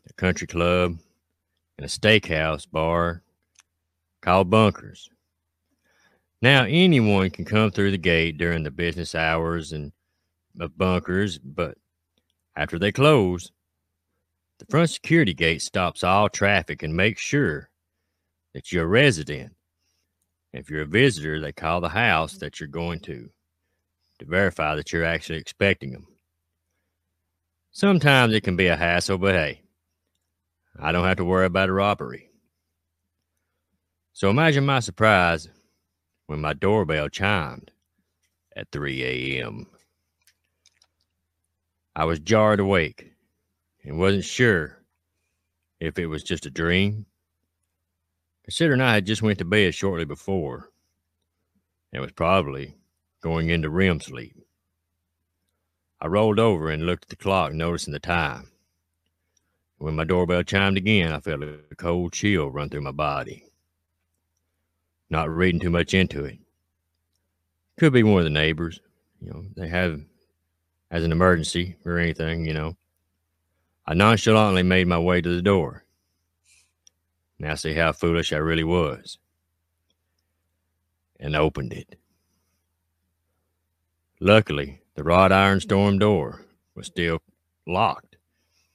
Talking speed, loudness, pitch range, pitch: 130 wpm, -22 LUFS, 80-90 Hz, 85 Hz